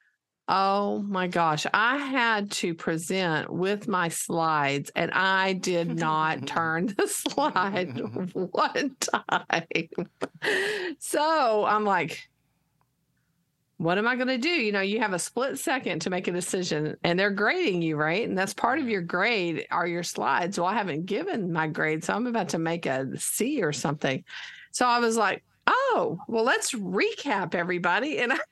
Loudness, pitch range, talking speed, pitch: -26 LUFS, 170-240 Hz, 165 wpm, 190 Hz